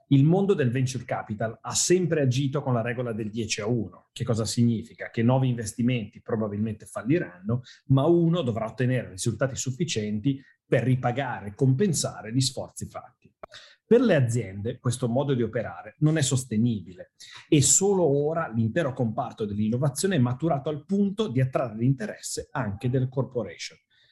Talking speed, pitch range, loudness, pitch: 155 wpm, 115-140 Hz, -26 LUFS, 125 Hz